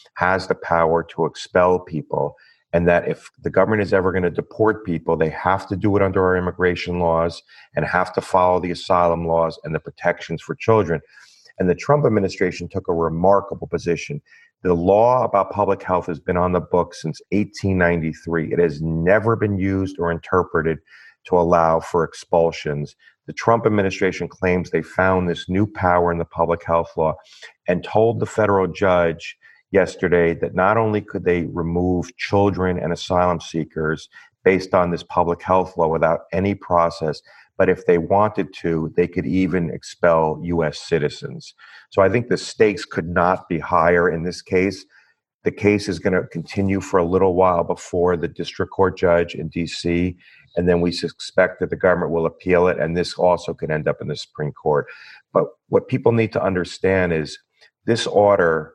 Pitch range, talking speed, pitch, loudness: 85-95 Hz, 180 wpm, 90 Hz, -20 LUFS